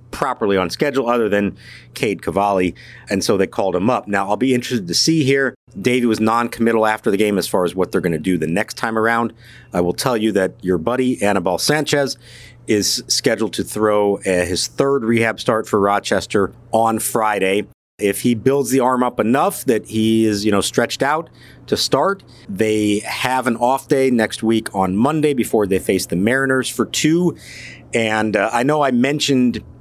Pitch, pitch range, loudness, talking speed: 115 Hz, 100-125 Hz, -18 LUFS, 195 wpm